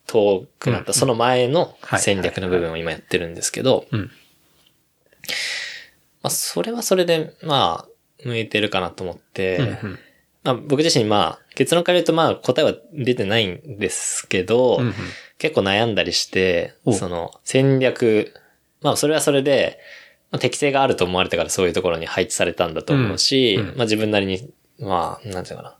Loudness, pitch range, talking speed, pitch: -20 LUFS, 100-150 Hz, 315 characters per minute, 125 Hz